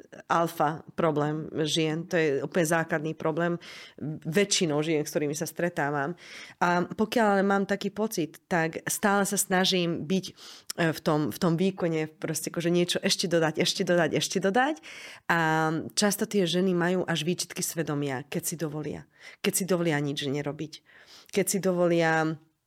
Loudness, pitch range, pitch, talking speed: -27 LUFS, 155-185 Hz, 170 Hz, 155 wpm